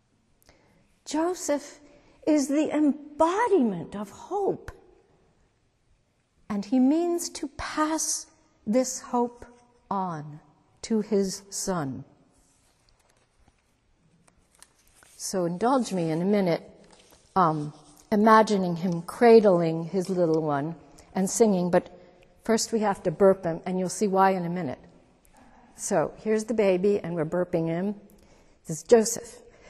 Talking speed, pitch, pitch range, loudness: 115 wpm, 200 Hz, 175-245 Hz, -25 LUFS